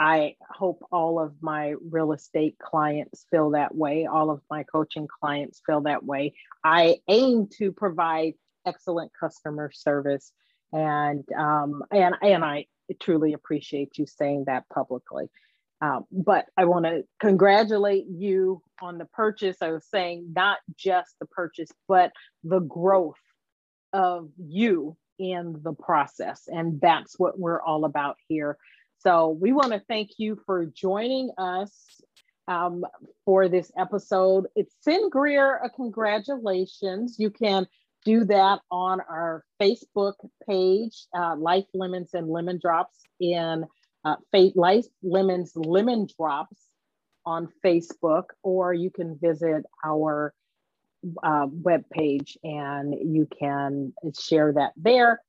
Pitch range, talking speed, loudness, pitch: 155-195 Hz, 135 wpm, -25 LUFS, 175 Hz